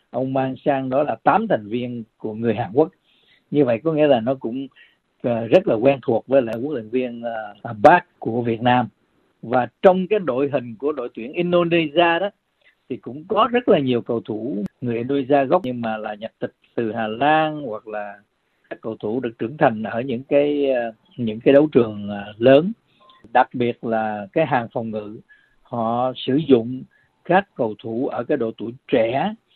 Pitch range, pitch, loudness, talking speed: 115-150 Hz, 130 Hz, -20 LUFS, 195 wpm